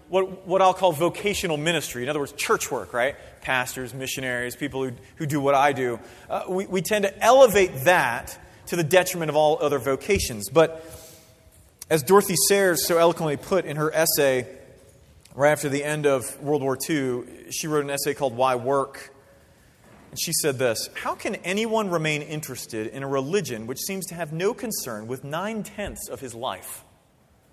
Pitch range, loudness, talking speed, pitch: 135-180 Hz, -23 LUFS, 185 wpm, 150 Hz